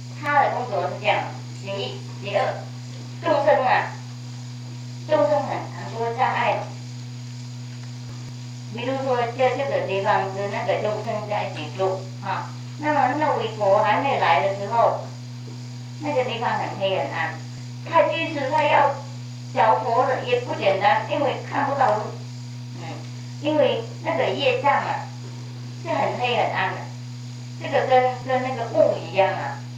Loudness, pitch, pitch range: -23 LUFS, 125 Hz, 120-140 Hz